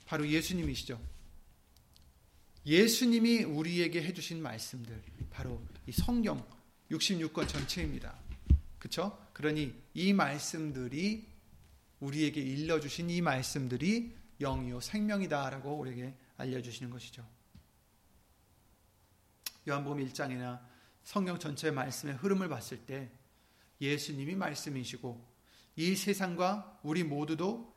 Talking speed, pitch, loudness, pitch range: 255 characters per minute, 140 Hz, -35 LUFS, 115-170 Hz